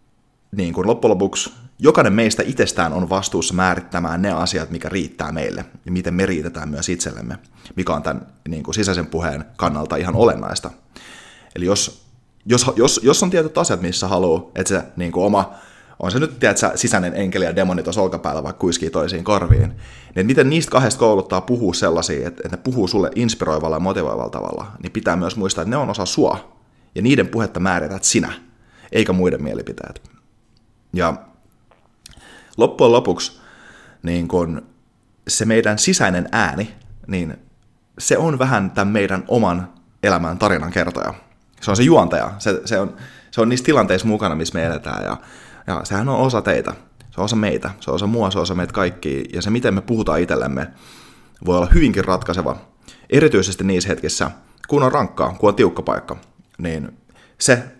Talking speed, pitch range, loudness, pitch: 175 wpm, 85-105 Hz, -19 LUFS, 95 Hz